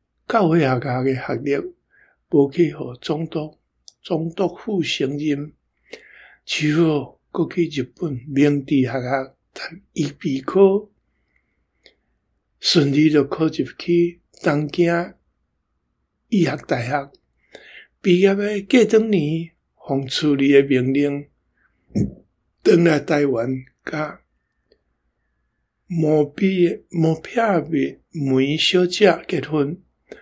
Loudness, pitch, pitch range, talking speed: -20 LUFS, 150 Hz, 135-170 Hz, 140 characters per minute